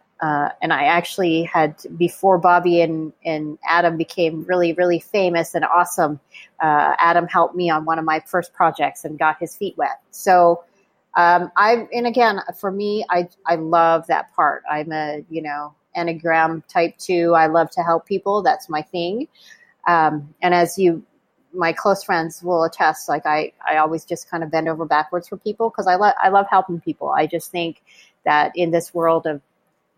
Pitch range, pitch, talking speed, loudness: 160-185 Hz, 170 Hz, 190 wpm, -19 LUFS